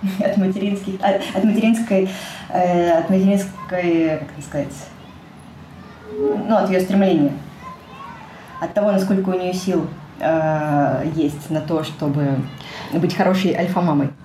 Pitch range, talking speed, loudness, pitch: 155-195 Hz, 130 wpm, -19 LUFS, 175 Hz